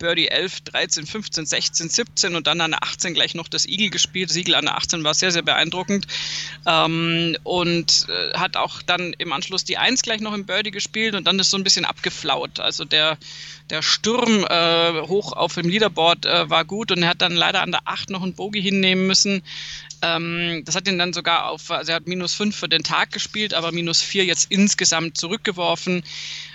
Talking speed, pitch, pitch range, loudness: 210 wpm, 175 Hz, 165-195 Hz, -19 LUFS